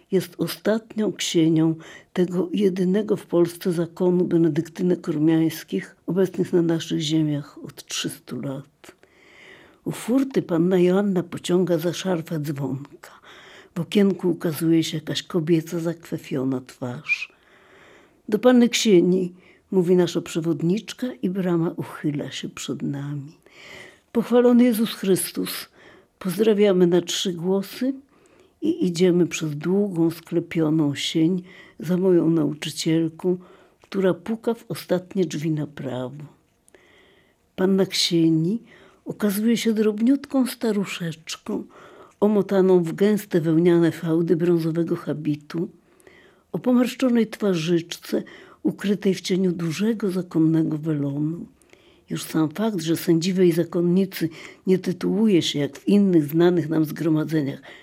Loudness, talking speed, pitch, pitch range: -22 LUFS, 110 wpm, 175 Hz, 165-195 Hz